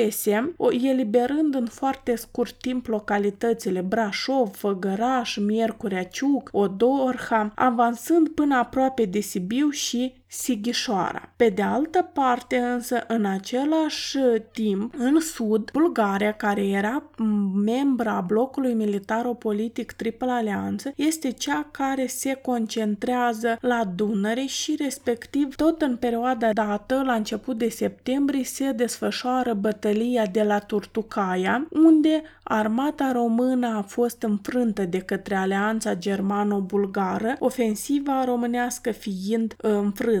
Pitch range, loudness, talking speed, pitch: 215-260 Hz, -24 LUFS, 115 wpm, 235 Hz